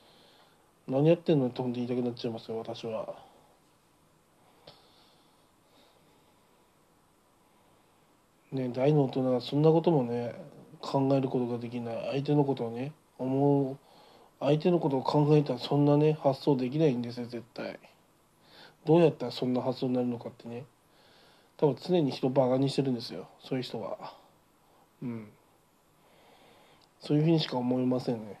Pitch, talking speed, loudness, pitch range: 130 Hz, 295 characters per minute, -29 LUFS, 120-145 Hz